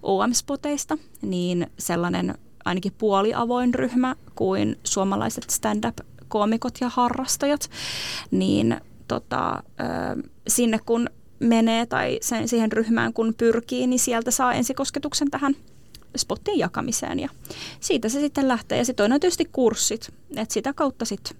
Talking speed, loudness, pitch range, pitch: 125 wpm, -24 LUFS, 220-275 Hz, 245 Hz